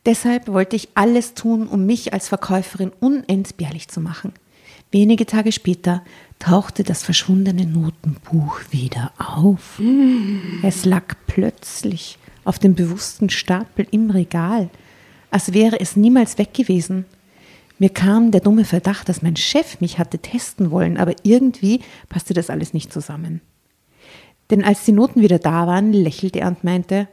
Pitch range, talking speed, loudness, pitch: 175-215 Hz, 145 wpm, -18 LUFS, 190 Hz